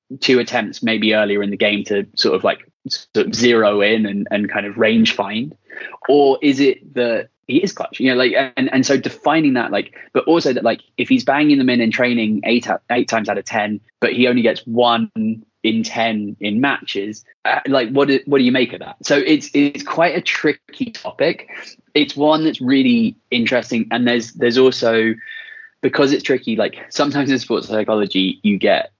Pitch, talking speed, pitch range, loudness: 125 Hz, 205 wpm, 110-150 Hz, -17 LUFS